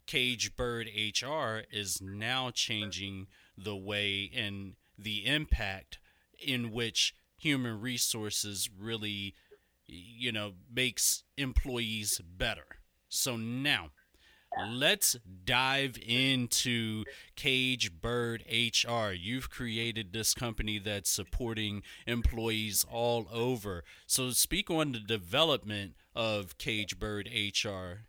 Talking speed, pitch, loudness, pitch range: 100 wpm, 115 Hz, -32 LUFS, 105-125 Hz